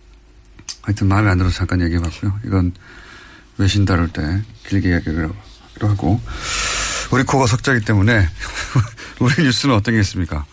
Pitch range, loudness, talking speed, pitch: 90-110 Hz, -18 LUFS, 325 characters per minute, 100 Hz